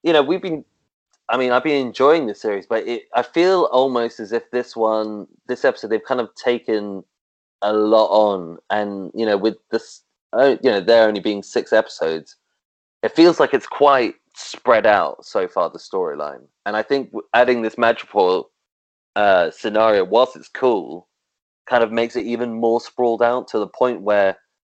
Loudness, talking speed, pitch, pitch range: -19 LUFS, 180 wpm, 120 Hz, 110-140 Hz